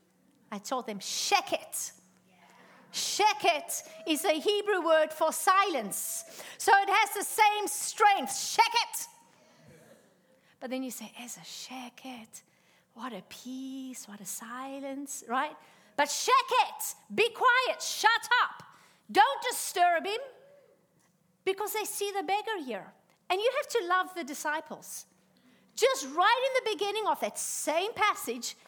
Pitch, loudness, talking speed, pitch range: 360 Hz, -29 LUFS, 140 wpm, 260-425 Hz